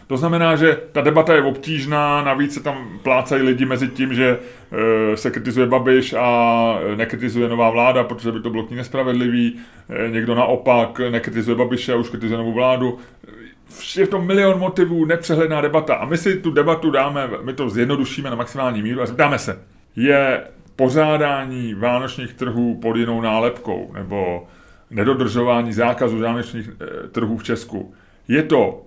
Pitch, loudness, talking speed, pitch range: 125 Hz, -18 LUFS, 155 wpm, 115-140 Hz